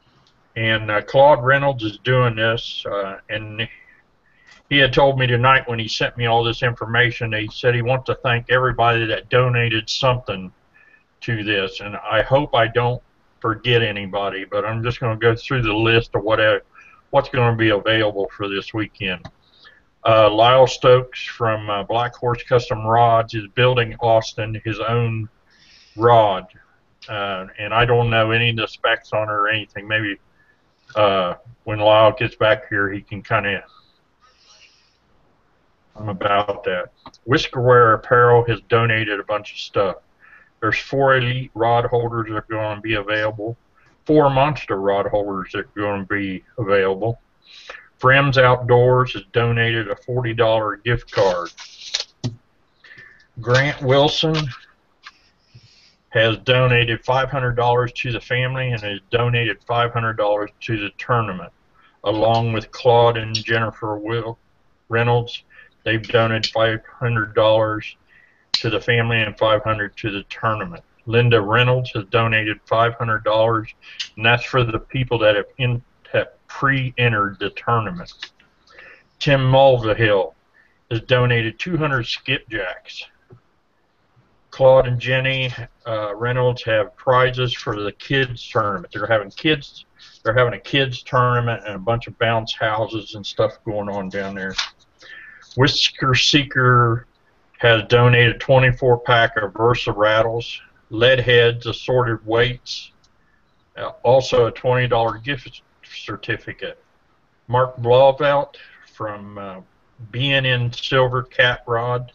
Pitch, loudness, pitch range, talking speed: 115 Hz, -18 LUFS, 110-125 Hz, 135 wpm